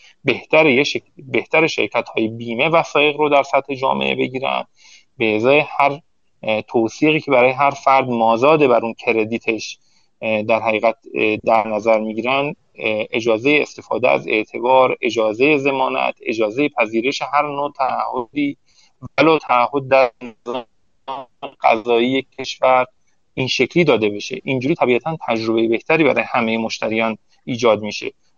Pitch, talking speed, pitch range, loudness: 125 Hz, 120 wpm, 110-140 Hz, -17 LUFS